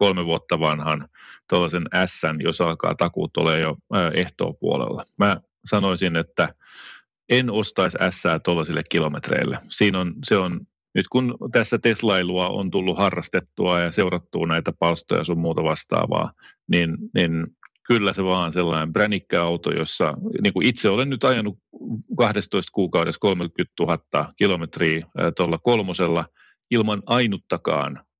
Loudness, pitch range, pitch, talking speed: -22 LUFS, 85-105 Hz, 90 Hz, 130 wpm